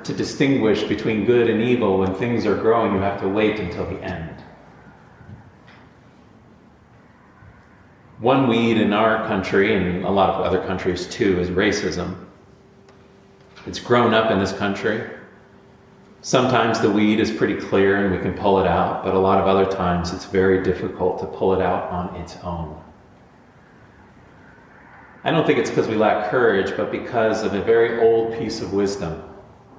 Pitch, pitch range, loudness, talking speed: 95 Hz, 90-110 Hz, -20 LUFS, 165 wpm